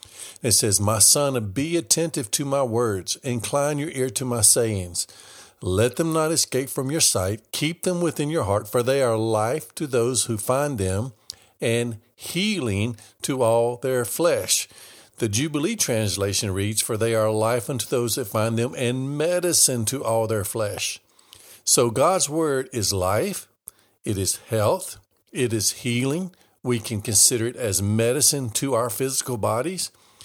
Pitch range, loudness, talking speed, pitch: 110-140 Hz, -22 LUFS, 165 wpm, 120 Hz